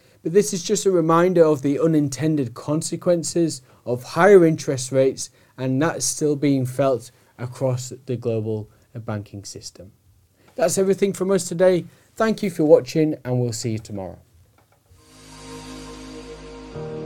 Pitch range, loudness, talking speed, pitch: 110-165 Hz, -20 LUFS, 135 wpm, 130 Hz